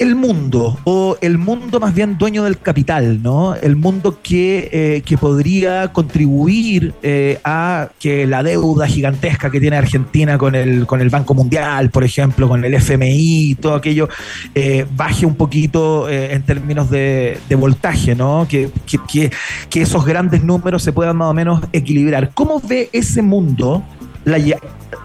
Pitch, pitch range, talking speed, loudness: 150 Hz, 140-170 Hz, 170 wpm, -14 LUFS